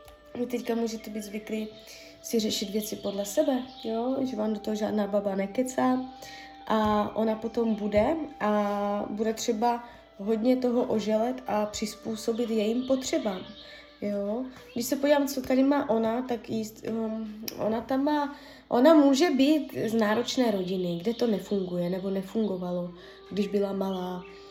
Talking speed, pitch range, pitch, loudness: 145 wpm, 205-255 Hz, 220 Hz, -28 LUFS